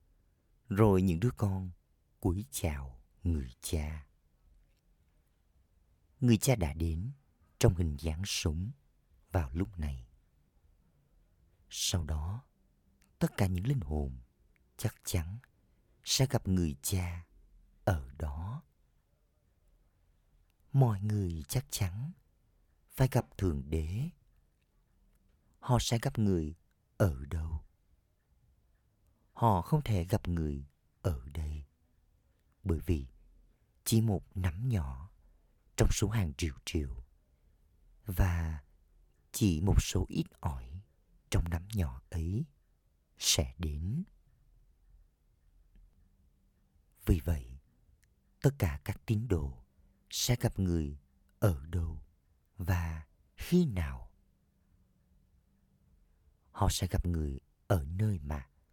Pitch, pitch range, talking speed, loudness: 85 Hz, 75-100 Hz, 100 wpm, -34 LUFS